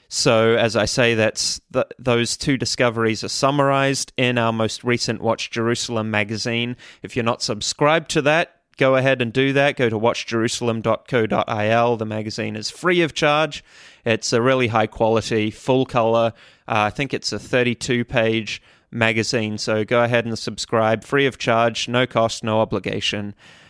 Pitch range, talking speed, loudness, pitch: 110-130 Hz, 165 wpm, -20 LUFS, 115 Hz